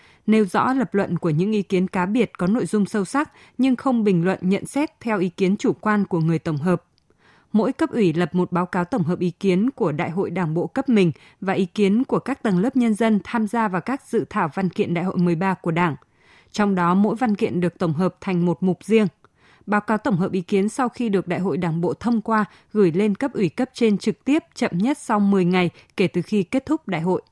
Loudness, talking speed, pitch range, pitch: -22 LUFS, 255 wpm, 180-225 Hz, 200 Hz